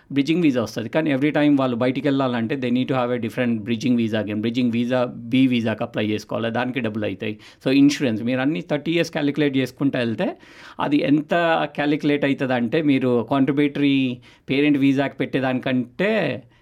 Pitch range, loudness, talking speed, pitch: 120-145 Hz, -21 LUFS, 160 wpm, 130 Hz